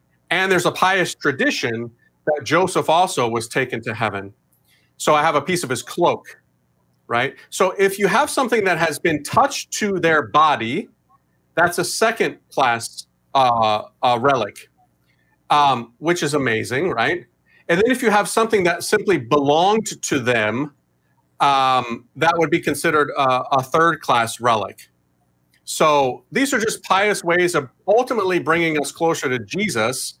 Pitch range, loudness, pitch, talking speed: 115-175 Hz, -19 LUFS, 150 Hz, 155 wpm